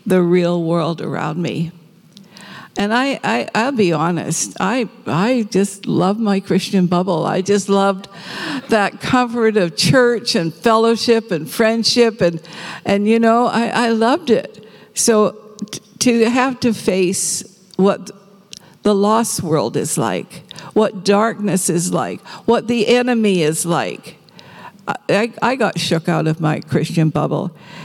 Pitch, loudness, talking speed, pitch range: 200 Hz, -17 LUFS, 140 wpm, 175-225 Hz